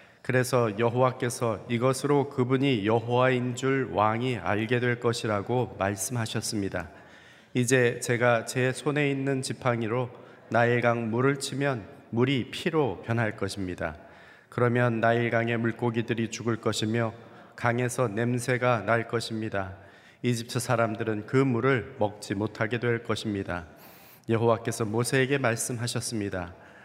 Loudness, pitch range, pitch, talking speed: -27 LUFS, 110-125 Hz, 120 Hz, 290 characters per minute